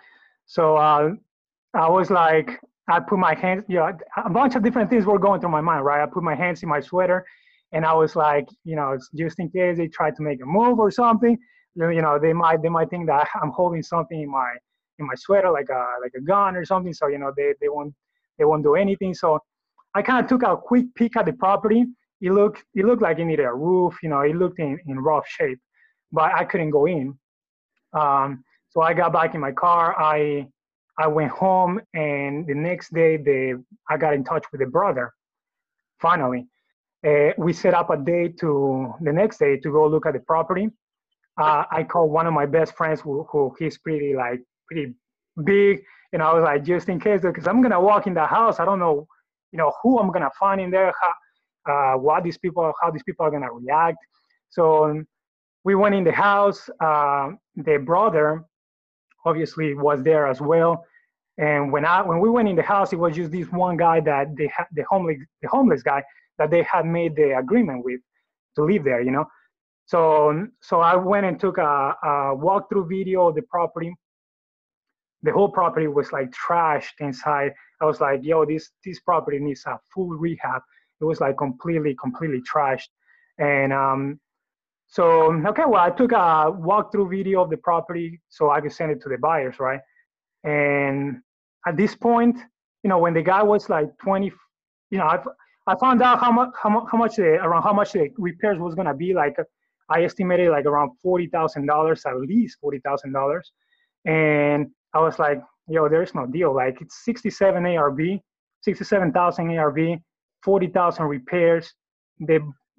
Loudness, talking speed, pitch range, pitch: -21 LUFS, 205 wpm, 150-195 Hz, 165 Hz